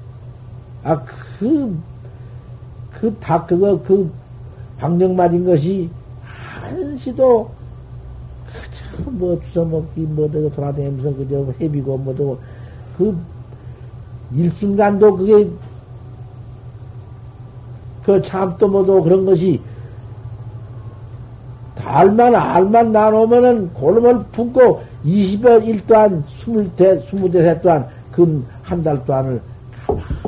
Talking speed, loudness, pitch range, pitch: 170 characters per minute, -15 LUFS, 120-190 Hz, 145 Hz